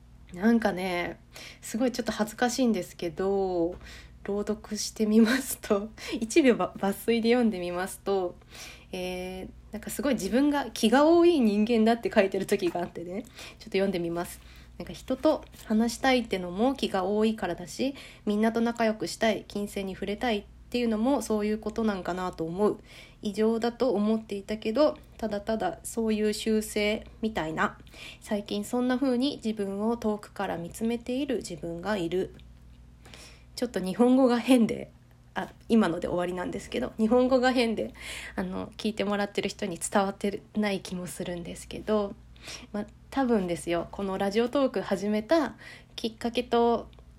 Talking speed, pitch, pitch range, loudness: 350 characters per minute, 210 Hz, 190-235 Hz, -28 LUFS